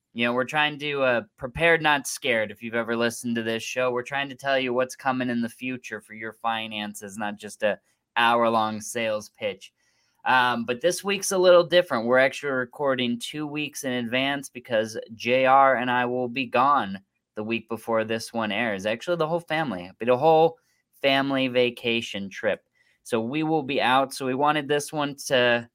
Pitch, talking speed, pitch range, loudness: 125 Hz, 195 wpm, 115-140 Hz, -24 LUFS